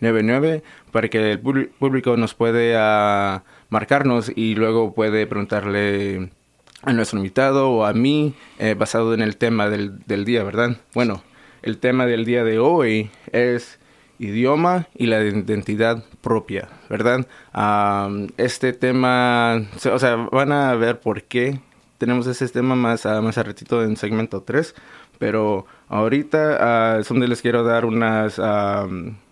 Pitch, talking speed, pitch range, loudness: 115 Hz, 145 wpm, 105-125 Hz, -20 LUFS